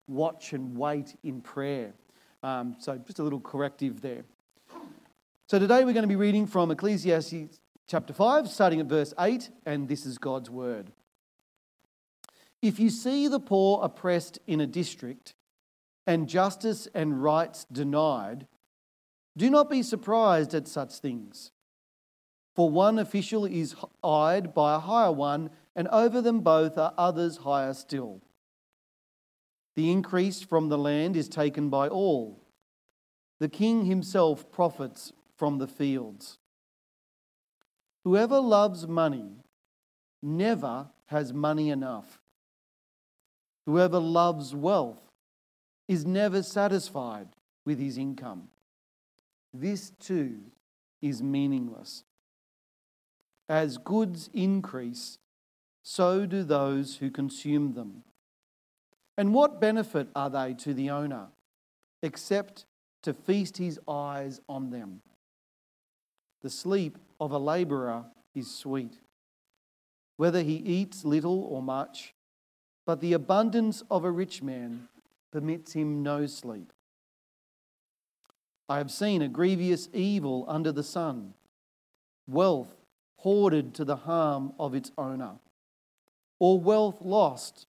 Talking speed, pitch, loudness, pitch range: 120 wpm, 155 Hz, -28 LUFS, 135-190 Hz